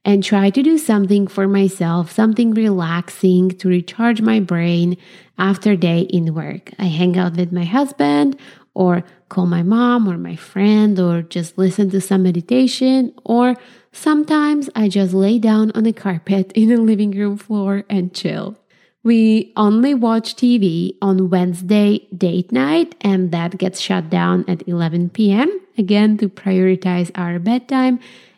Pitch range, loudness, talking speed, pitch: 180-225 Hz, -16 LUFS, 155 wpm, 195 Hz